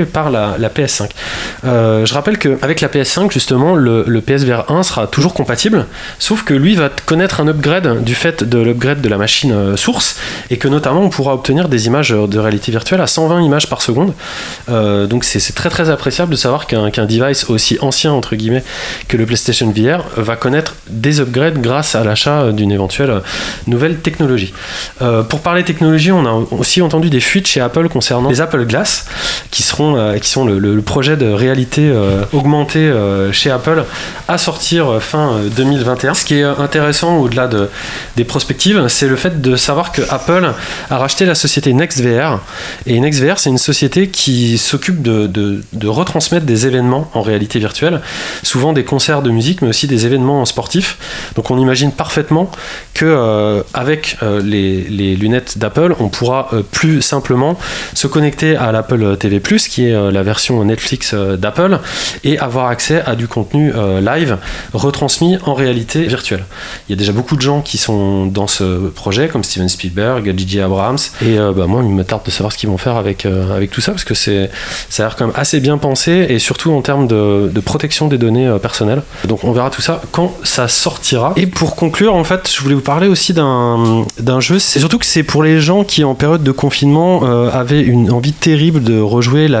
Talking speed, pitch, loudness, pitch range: 195 wpm, 130 Hz, -12 LUFS, 110-155 Hz